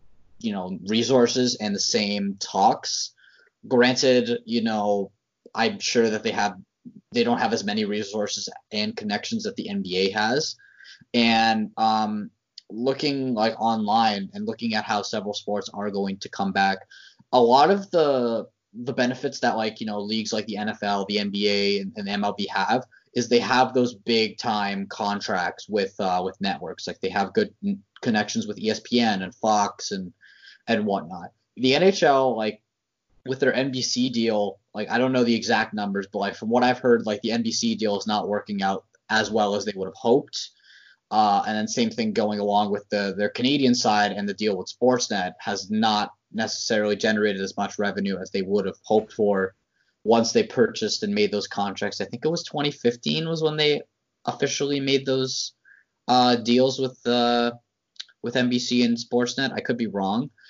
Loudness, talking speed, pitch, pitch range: -24 LUFS, 180 wpm, 115 Hz, 105-130 Hz